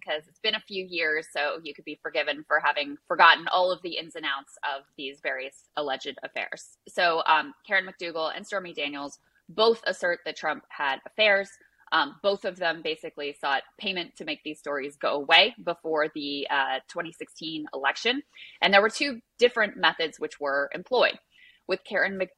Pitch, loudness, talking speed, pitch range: 170 Hz, -26 LUFS, 180 wpm, 150-200 Hz